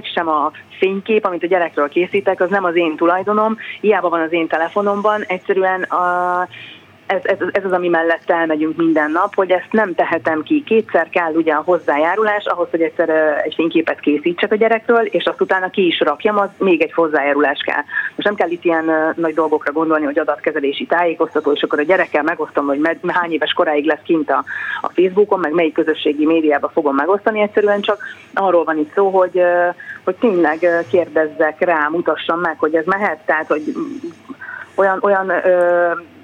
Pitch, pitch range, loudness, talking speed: 175 Hz, 160-200 Hz, -16 LUFS, 175 wpm